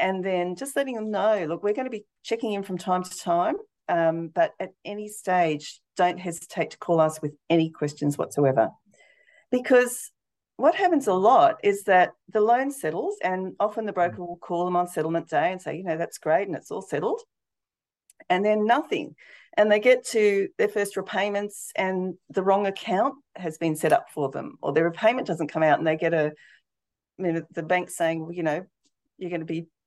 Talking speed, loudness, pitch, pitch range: 205 wpm, -25 LUFS, 190 Hz, 165-240 Hz